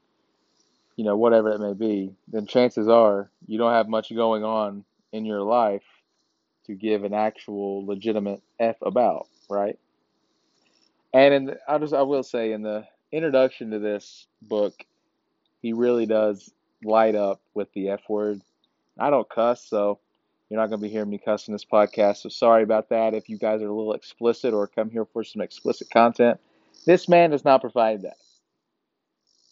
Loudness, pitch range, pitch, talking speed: -23 LUFS, 105-115 Hz, 110 Hz, 175 wpm